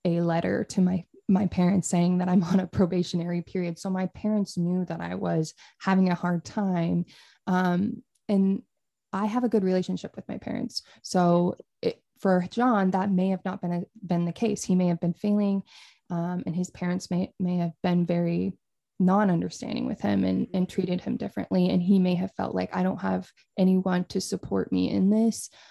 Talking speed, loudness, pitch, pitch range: 200 wpm, -27 LUFS, 185 Hz, 175-195 Hz